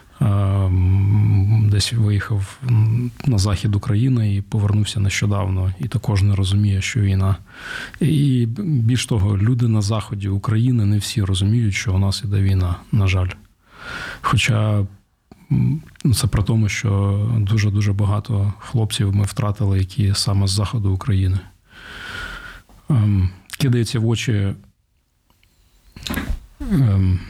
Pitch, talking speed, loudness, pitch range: 105 Hz, 115 wpm, -19 LUFS, 100-115 Hz